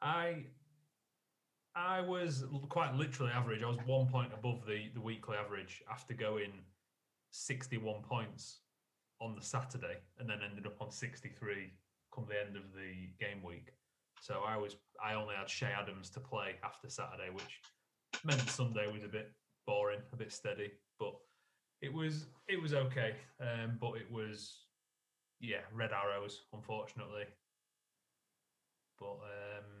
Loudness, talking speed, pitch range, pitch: -42 LUFS, 145 wpm, 105-130 Hz, 110 Hz